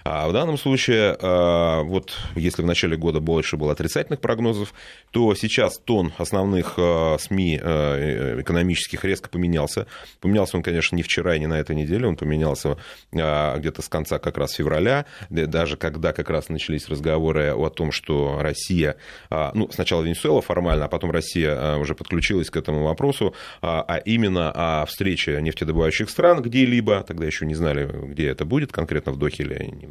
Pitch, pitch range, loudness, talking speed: 85 Hz, 75-95 Hz, -22 LUFS, 160 wpm